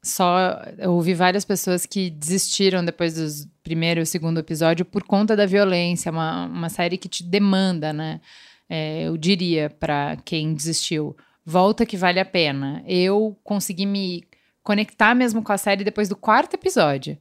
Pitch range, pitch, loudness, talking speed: 165-200 Hz, 180 Hz, -21 LUFS, 165 wpm